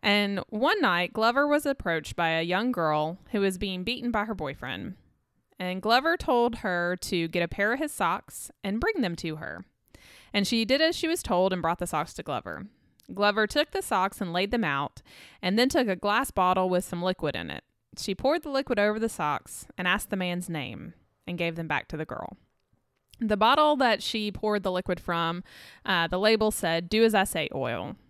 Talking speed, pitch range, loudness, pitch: 215 wpm, 175-230 Hz, -27 LUFS, 200 Hz